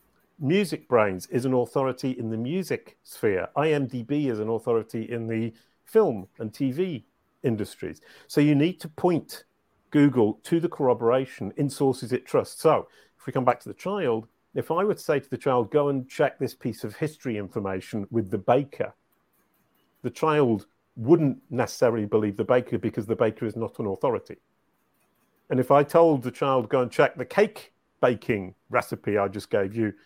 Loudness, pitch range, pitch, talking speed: -26 LUFS, 115-145 Hz, 125 Hz, 180 wpm